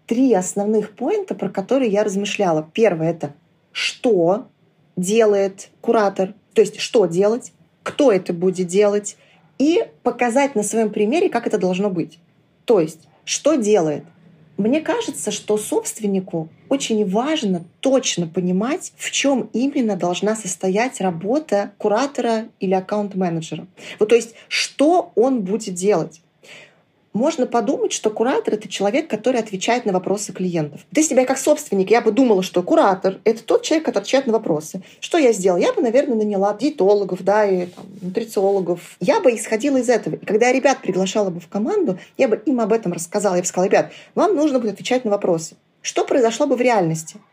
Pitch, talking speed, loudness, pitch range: 210 Hz, 165 wpm, -19 LUFS, 185-240 Hz